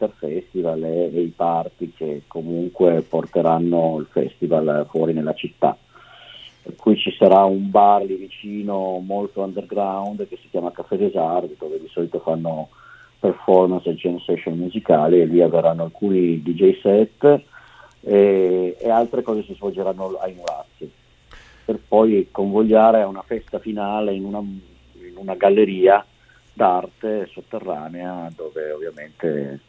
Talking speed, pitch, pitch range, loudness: 135 wpm, 95 Hz, 85-105 Hz, -19 LUFS